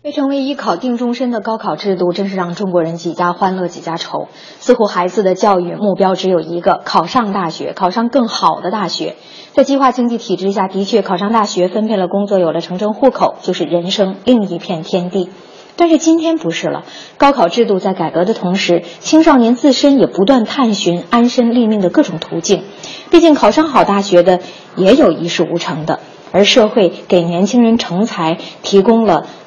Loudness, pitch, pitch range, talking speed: -13 LUFS, 200 Hz, 180-240 Hz, 300 characters per minute